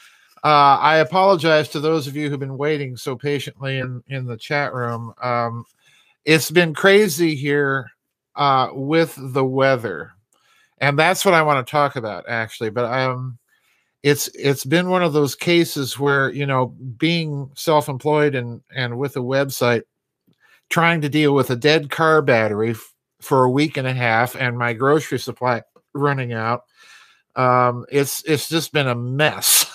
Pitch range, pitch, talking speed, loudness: 125-155 Hz, 140 Hz, 165 wpm, -19 LUFS